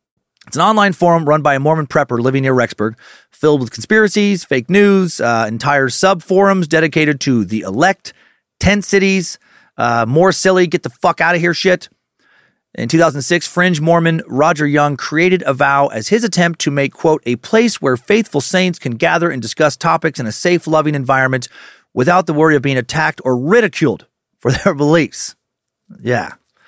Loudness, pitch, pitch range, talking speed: -14 LUFS, 155 Hz, 135-180 Hz, 180 wpm